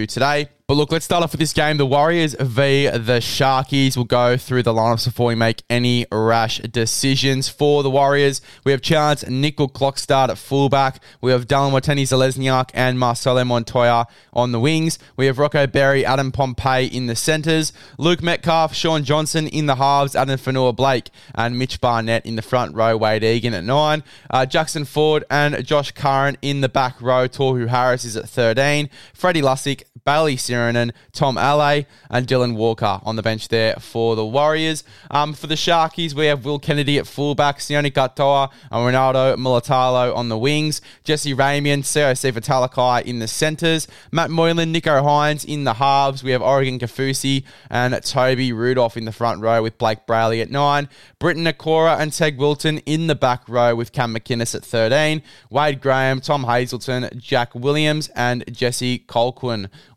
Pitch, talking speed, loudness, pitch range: 135 Hz, 180 wpm, -18 LUFS, 120-145 Hz